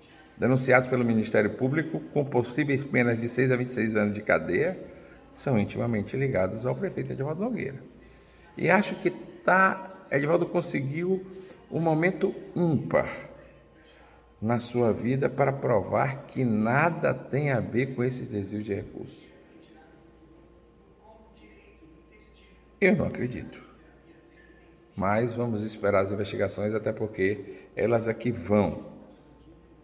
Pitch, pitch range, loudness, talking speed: 125 Hz, 110-150 Hz, -27 LUFS, 115 wpm